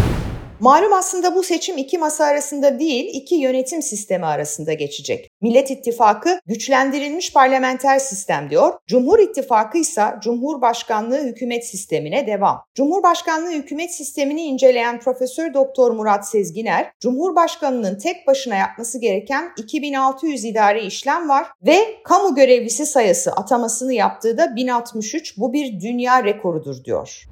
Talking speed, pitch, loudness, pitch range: 125 wpm, 265 Hz, -18 LUFS, 225-315 Hz